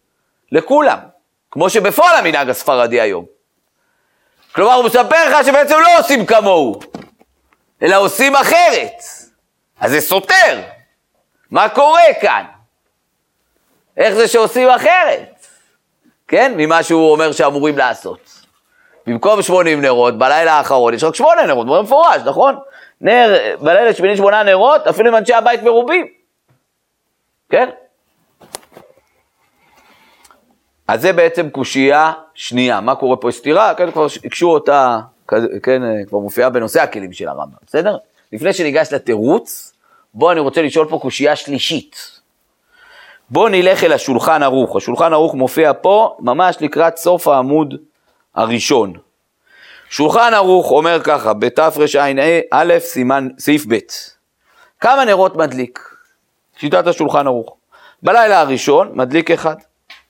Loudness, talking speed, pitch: -12 LUFS, 120 wpm, 165 Hz